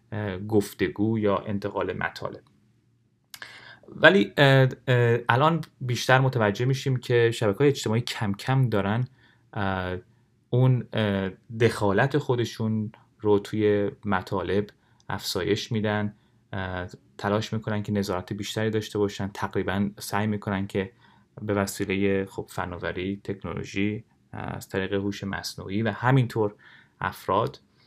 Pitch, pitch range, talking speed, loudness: 105 Hz, 100-120 Hz, 100 wpm, -26 LUFS